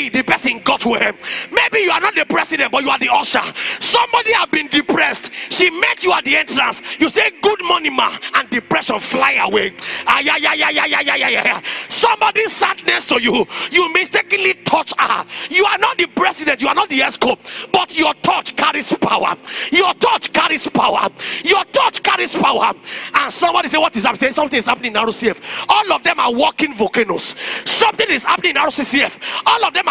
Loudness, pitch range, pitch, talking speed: -15 LUFS, 295-415 Hz, 355 Hz, 185 wpm